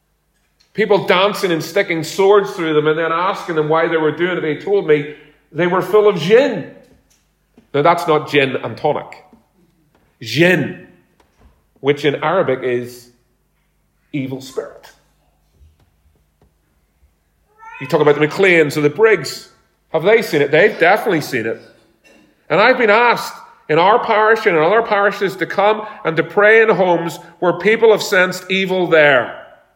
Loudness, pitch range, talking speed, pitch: -15 LUFS, 145-200 Hz, 155 wpm, 165 Hz